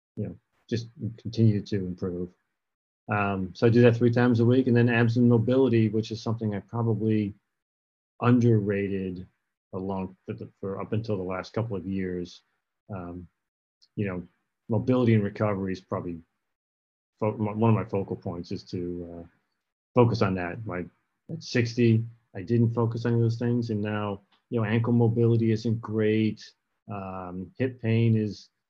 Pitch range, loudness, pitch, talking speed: 95-115 Hz, -26 LUFS, 110 Hz, 160 wpm